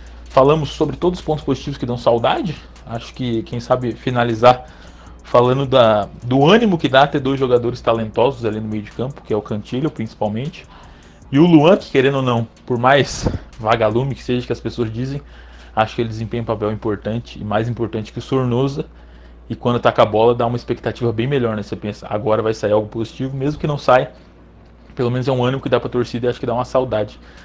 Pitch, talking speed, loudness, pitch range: 120 Hz, 220 wpm, -18 LUFS, 110-130 Hz